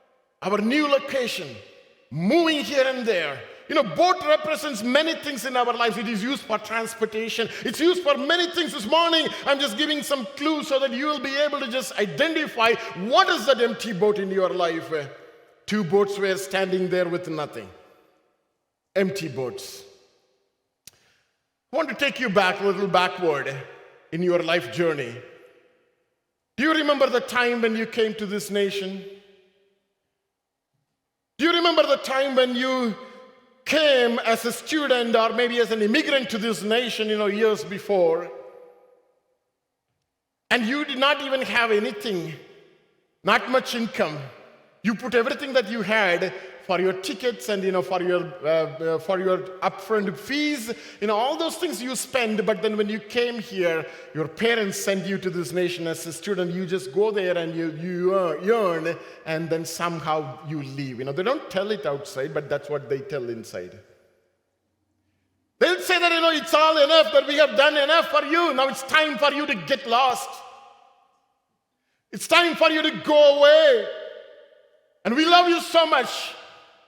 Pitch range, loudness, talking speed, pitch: 190-295 Hz, -22 LUFS, 175 wpm, 230 Hz